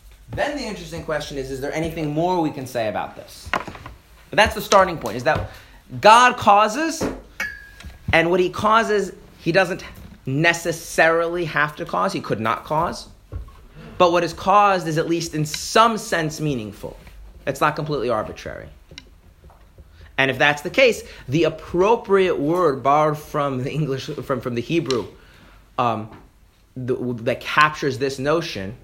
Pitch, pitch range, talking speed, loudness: 155 Hz, 130-180 Hz, 155 wpm, -20 LUFS